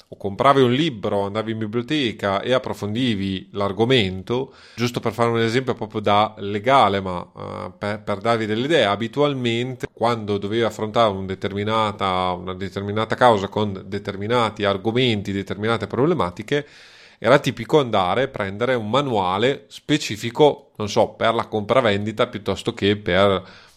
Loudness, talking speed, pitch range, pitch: -21 LUFS, 140 wpm, 100-120 Hz, 110 Hz